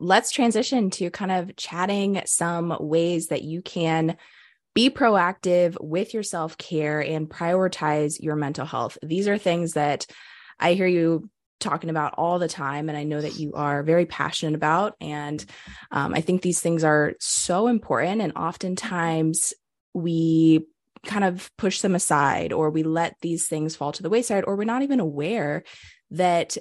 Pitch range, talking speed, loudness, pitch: 155-185 Hz, 170 wpm, -24 LUFS, 170 Hz